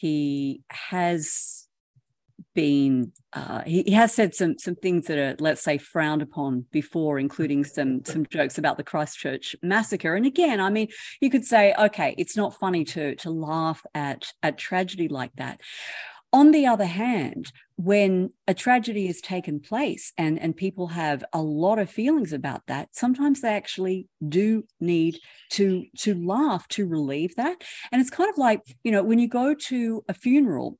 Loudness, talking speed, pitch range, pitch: -24 LUFS, 175 wpm, 150-220 Hz, 180 Hz